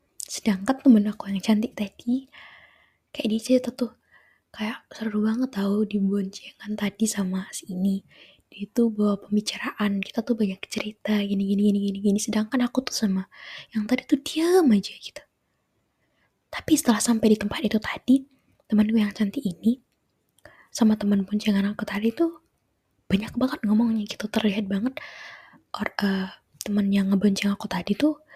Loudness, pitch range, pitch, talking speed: -25 LUFS, 200-245 Hz, 215 Hz, 155 wpm